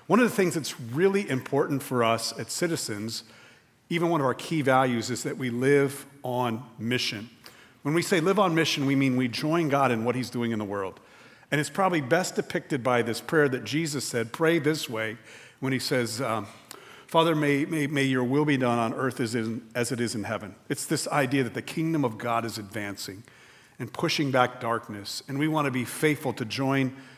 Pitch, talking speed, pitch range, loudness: 130 Hz, 215 wpm, 115-150 Hz, -27 LUFS